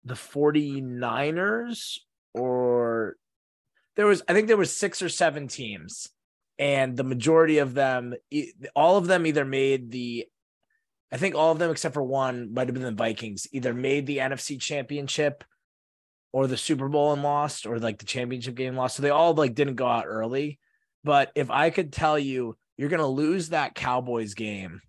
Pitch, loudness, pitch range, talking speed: 135 Hz, -26 LUFS, 125-155 Hz, 180 wpm